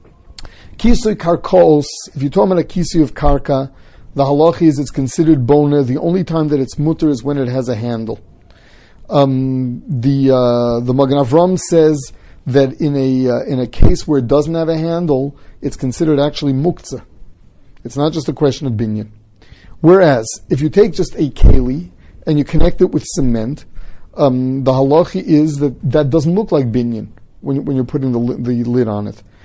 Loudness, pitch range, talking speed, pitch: -14 LUFS, 125-155 Hz, 180 wpm, 140 Hz